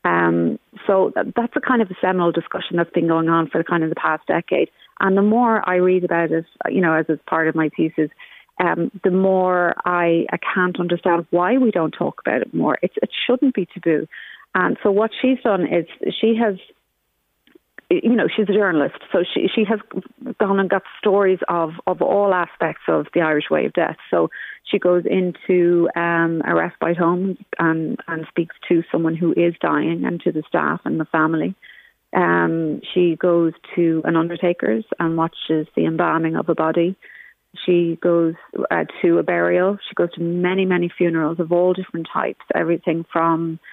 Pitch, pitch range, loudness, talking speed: 175 Hz, 165-190 Hz, -19 LUFS, 190 wpm